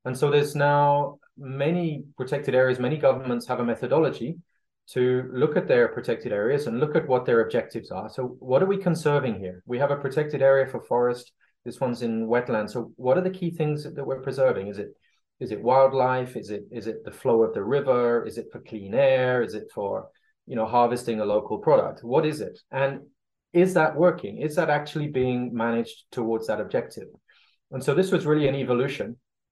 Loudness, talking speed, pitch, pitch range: -25 LUFS, 205 wpm, 130 Hz, 120-150 Hz